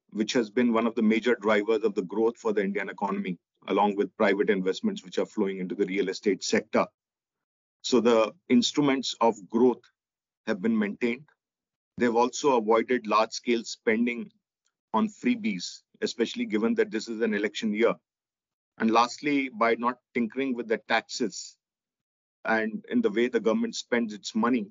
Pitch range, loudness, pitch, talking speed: 110-150 Hz, -27 LUFS, 120 Hz, 165 wpm